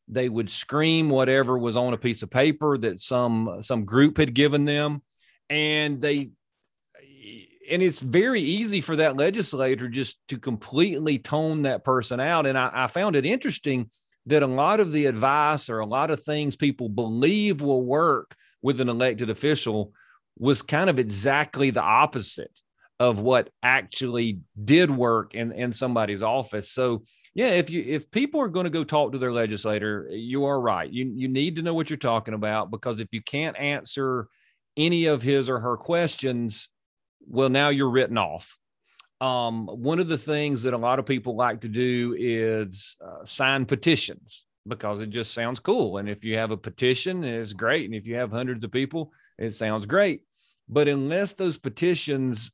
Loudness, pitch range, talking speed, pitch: -24 LUFS, 115-150 Hz, 180 wpm, 130 Hz